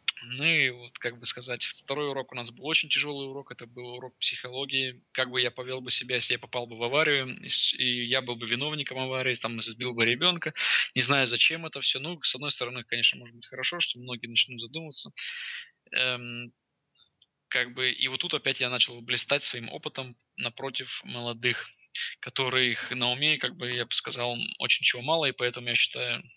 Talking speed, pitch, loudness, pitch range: 195 wpm, 125 Hz, -27 LUFS, 120-135 Hz